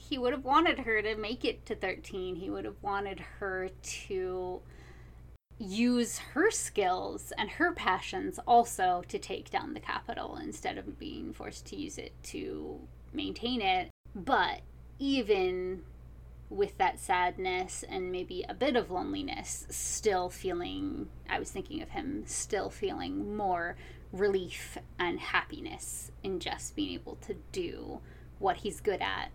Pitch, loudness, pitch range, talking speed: 200 Hz, -33 LUFS, 180-290 Hz, 145 wpm